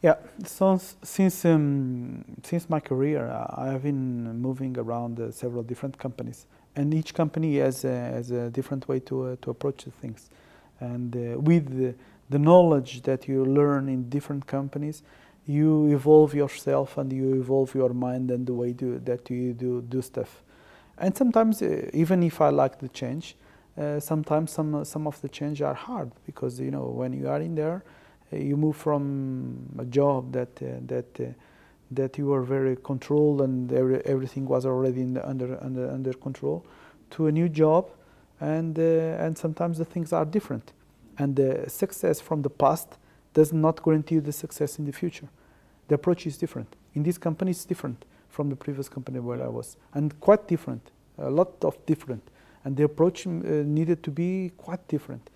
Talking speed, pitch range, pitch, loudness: 185 wpm, 130-160 Hz, 140 Hz, -26 LUFS